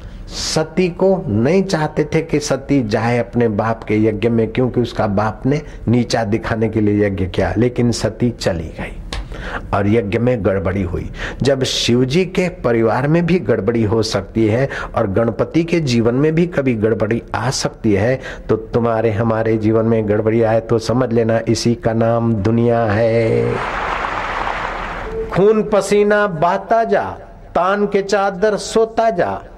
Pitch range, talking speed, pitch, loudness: 110-155 Hz, 155 wpm, 115 Hz, -17 LUFS